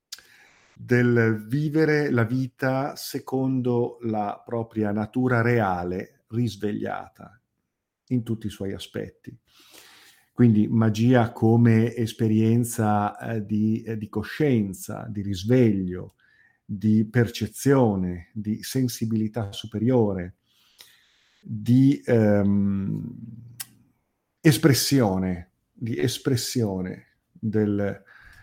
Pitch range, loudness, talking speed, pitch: 105-120 Hz, -24 LUFS, 80 wpm, 115 Hz